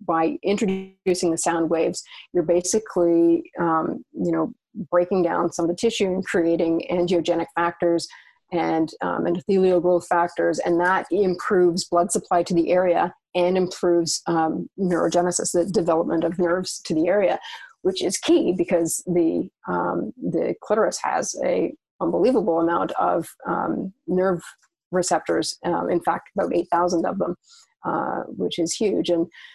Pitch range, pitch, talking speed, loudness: 170-185 Hz, 175 Hz, 150 wpm, -22 LUFS